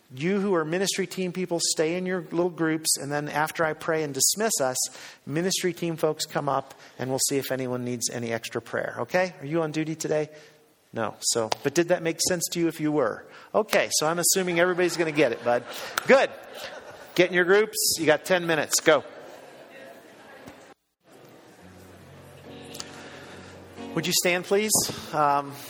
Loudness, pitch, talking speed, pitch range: -25 LUFS, 160 Hz, 175 wpm, 145-180 Hz